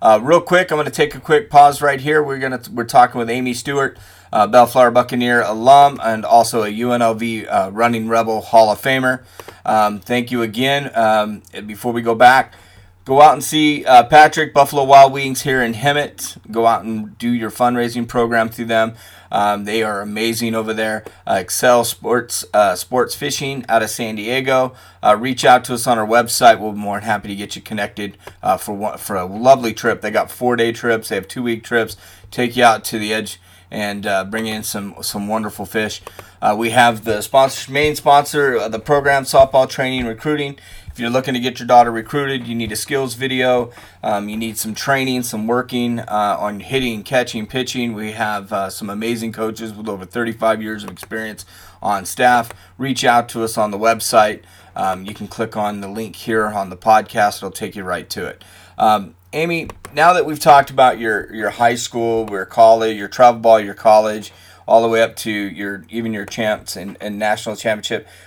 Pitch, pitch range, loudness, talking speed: 115 Hz, 105-125 Hz, -16 LUFS, 205 wpm